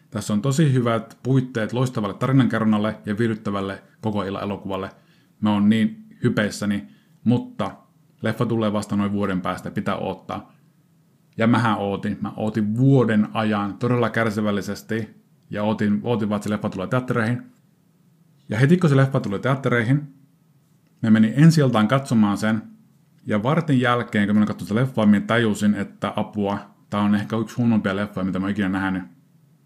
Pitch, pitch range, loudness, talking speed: 110 Hz, 105-135 Hz, -22 LUFS, 160 wpm